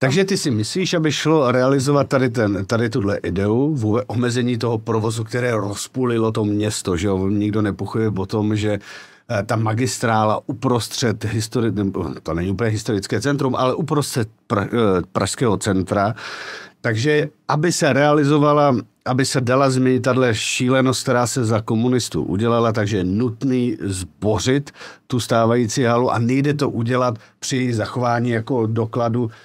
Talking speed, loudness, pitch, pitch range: 145 wpm, -19 LUFS, 120 Hz, 110-130 Hz